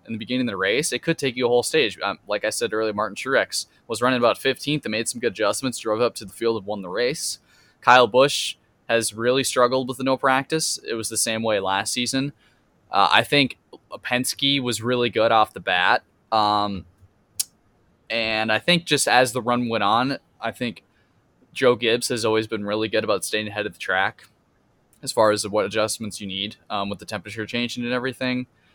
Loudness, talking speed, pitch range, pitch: -22 LUFS, 215 wpm, 105-125 Hz, 115 Hz